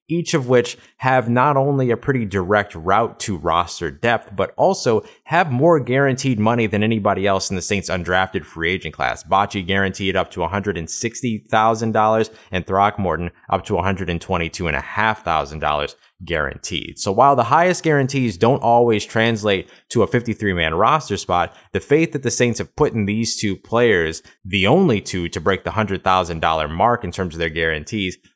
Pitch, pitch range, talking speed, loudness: 105 Hz, 95-120 Hz, 165 wpm, -19 LUFS